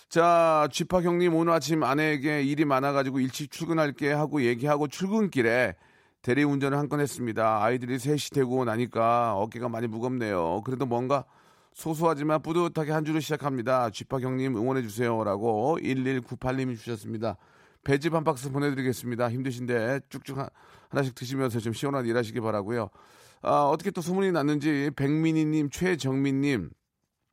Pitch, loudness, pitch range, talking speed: 135 Hz, -27 LUFS, 125-155 Hz, 360 characters per minute